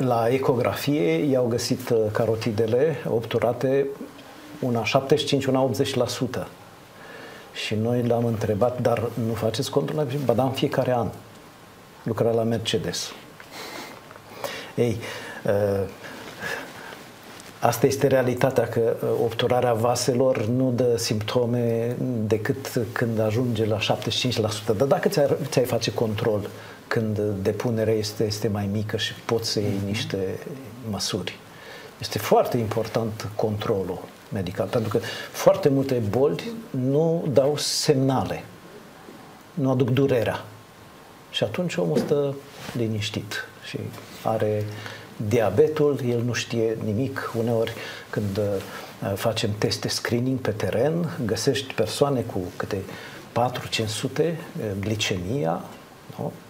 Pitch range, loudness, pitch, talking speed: 110-135 Hz, -24 LUFS, 120 Hz, 105 wpm